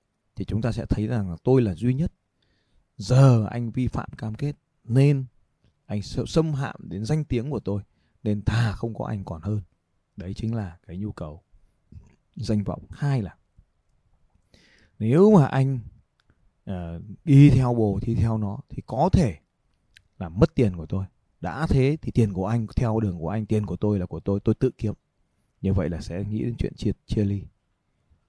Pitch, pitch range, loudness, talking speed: 110 Hz, 95-125 Hz, -24 LUFS, 195 wpm